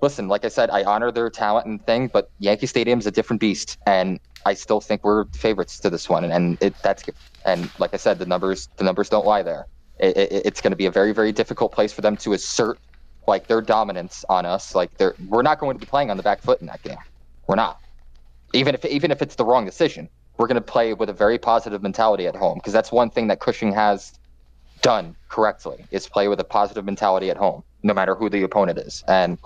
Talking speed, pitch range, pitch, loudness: 250 wpm, 90-115 Hz, 105 Hz, -21 LUFS